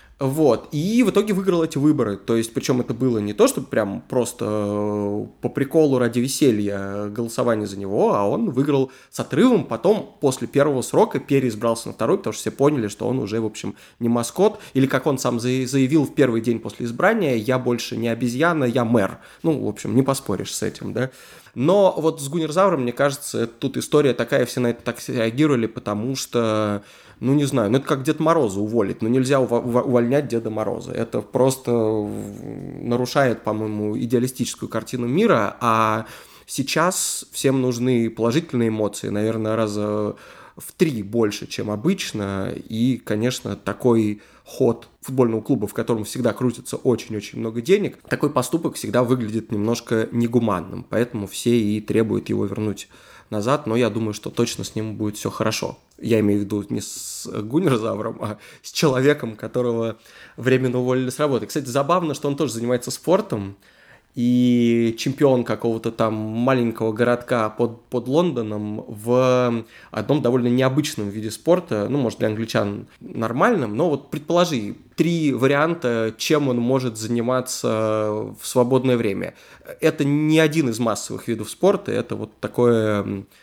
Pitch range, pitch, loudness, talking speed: 110-135 Hz, 120 Hz, -21 LUFS, 160 wpm